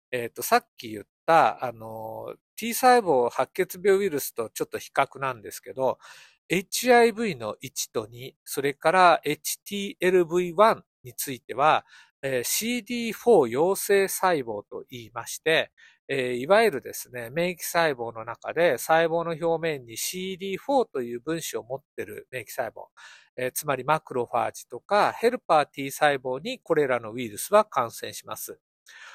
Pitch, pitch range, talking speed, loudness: 165 Hz, 125-205 Hz, 280 characters per minute, -25 LUFS